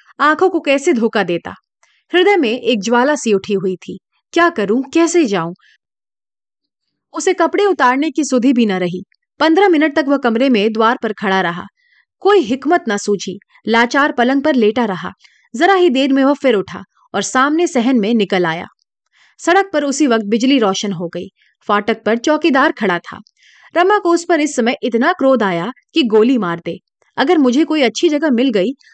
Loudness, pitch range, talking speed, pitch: -14 LUFS, 215-320 Hz, 185 wpm, 260 Hz